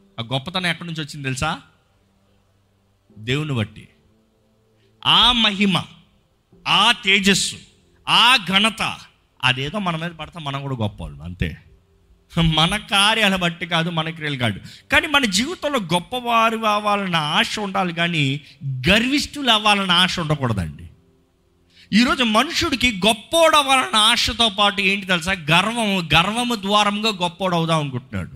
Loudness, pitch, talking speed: -18 LUFS, 175 Hz, 110 wpm